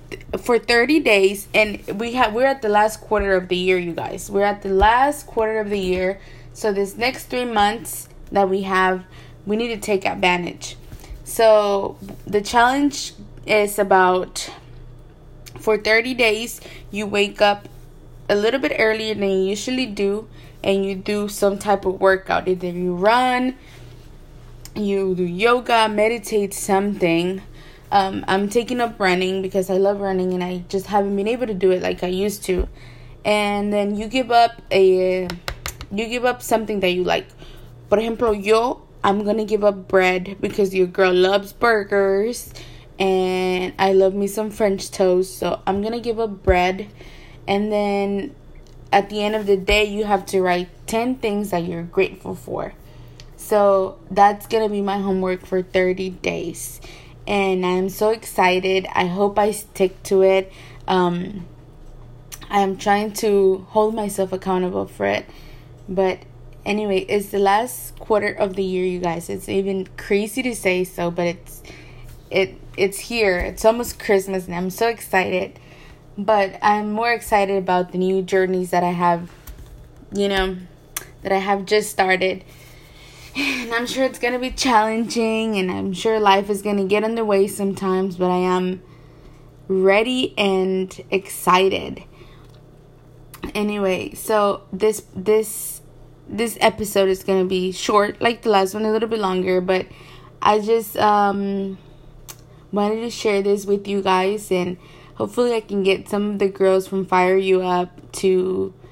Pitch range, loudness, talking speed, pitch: 185-210 Hz, -20 LUFS, 160 wpm, 195 Hz